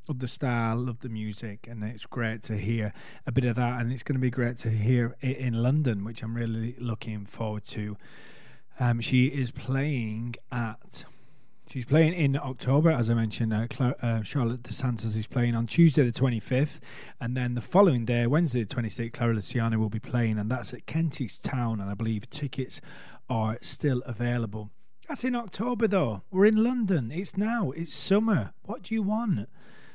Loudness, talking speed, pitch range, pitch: -28 LUFS, 190 wpm, 115-145 Hz, 120 Hz